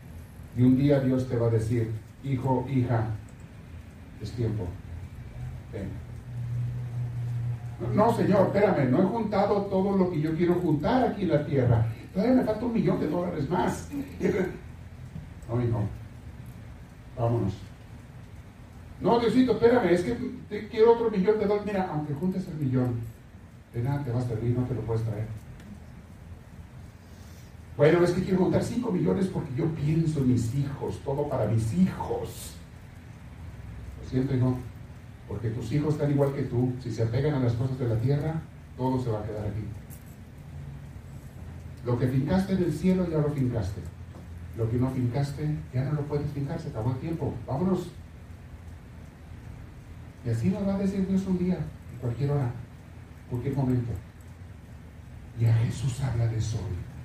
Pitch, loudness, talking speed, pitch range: 125 Hz, -27 LUFS, 160 wpm, 110-150 Hz